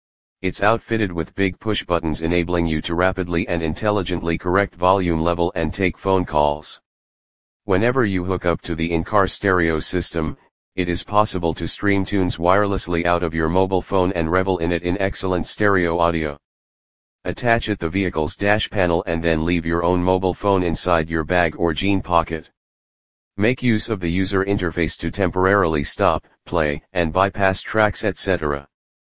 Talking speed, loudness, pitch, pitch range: 170 wpm, -20 LUFS, 90 Hz, 85-95 Hz